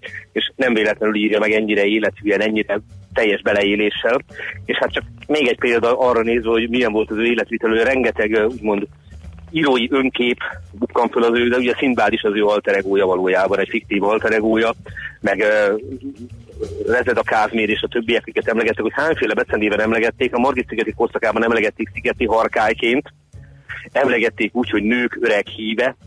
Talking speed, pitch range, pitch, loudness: 160 wpm, 105-120 Hz, 110 Hz, -18 LUFS